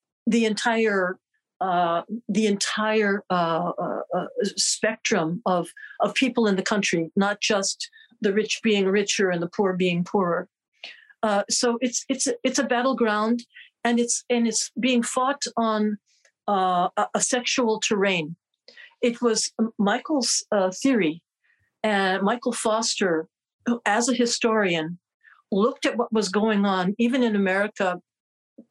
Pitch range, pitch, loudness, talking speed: 195-240 Hz, 215 Hz, -23 LUFS, 140 wpm